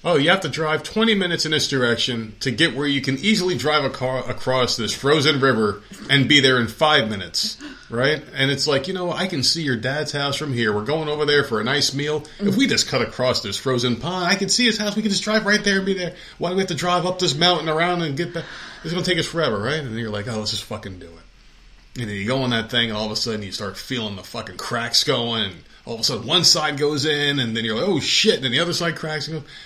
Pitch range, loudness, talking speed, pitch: 115-170 Hz, -20 LUFS, 290 wpm, 145 Hz